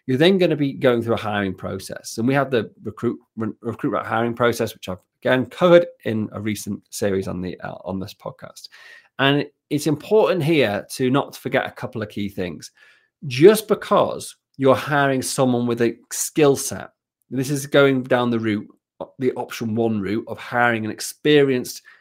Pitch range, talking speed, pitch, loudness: 110-140 Hz, 185 wpm, 120 Hz, -21 LUFS